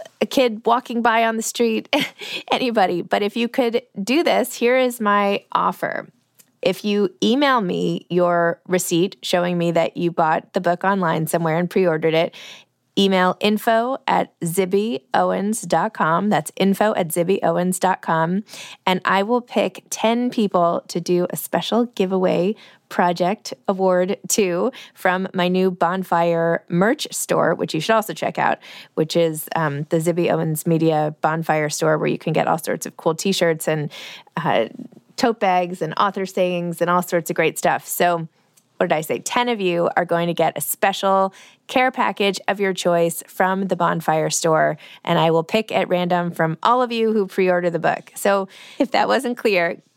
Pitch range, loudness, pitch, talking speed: 170-210 Hz, -20 LUFS, 185 Hz, 170 wpm